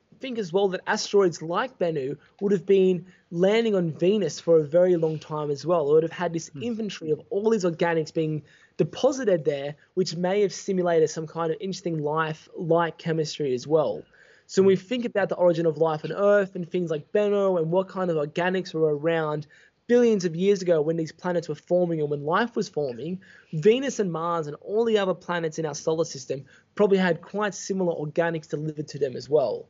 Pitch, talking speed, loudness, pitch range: 175 Hz, 210 wpm, -25 LUFS, 160-195 Hz